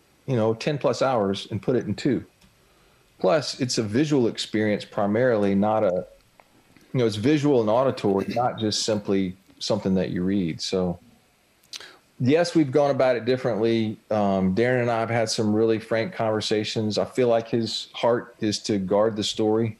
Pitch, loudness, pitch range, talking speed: 110 Hz, -24 LUFS, 100-115 Hz, 175 wpm